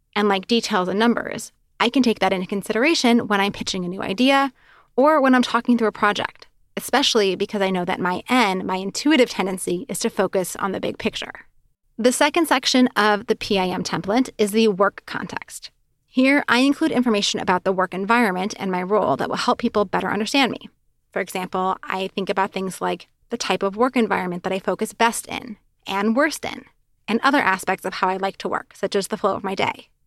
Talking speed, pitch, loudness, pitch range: 210 wpm, 210 Hz, -21 LUFS, 190-240 Hz